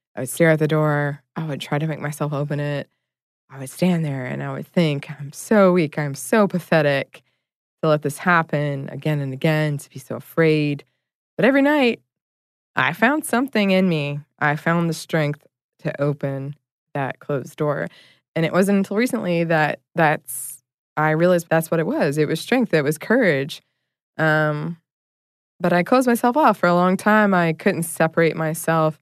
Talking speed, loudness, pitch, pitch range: 185 wpm, -20 LUFS, 155 Hz, 145-175 Hz